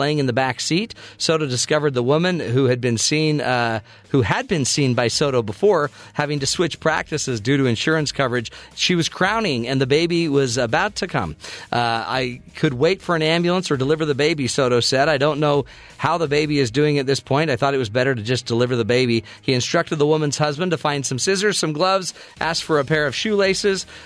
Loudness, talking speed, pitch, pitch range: -20 LUFS, 225 wpm, 145 Hz, 130-160 Hz